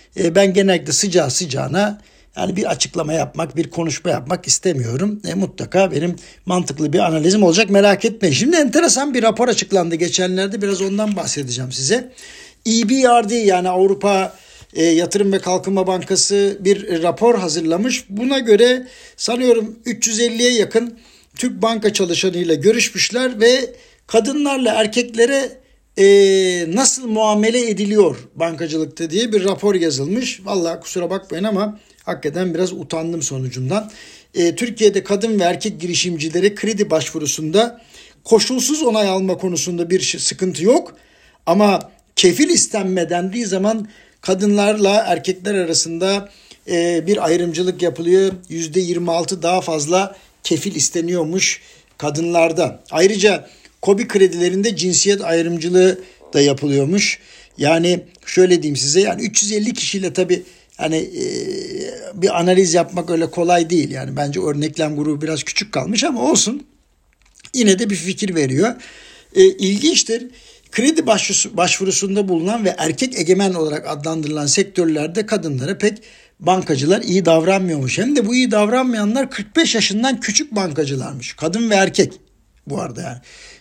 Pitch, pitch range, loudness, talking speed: 190 Hz, 170-220 Hz, -17 LUFS, 125 wpm